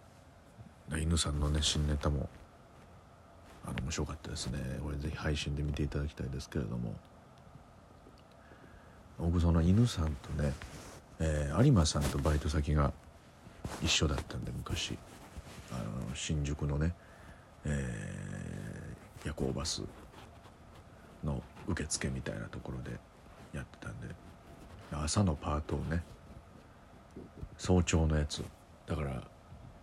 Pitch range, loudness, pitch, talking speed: 75-85 Hz, -35 LUFS, 75 Hz, 225 characters per minute